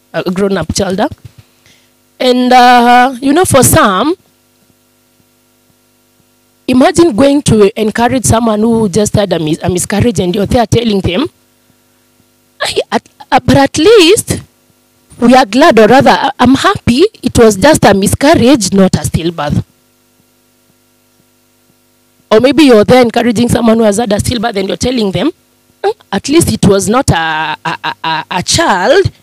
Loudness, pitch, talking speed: -9 LUFS, 215 Hz, 150 wpm